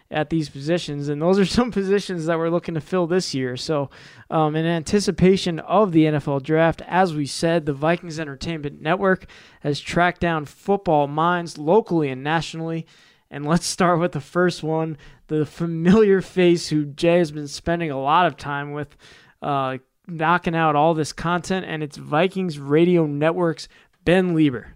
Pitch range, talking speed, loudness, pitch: 150-175 Hz, 170 wpm, -21 LUFS, 165 Hz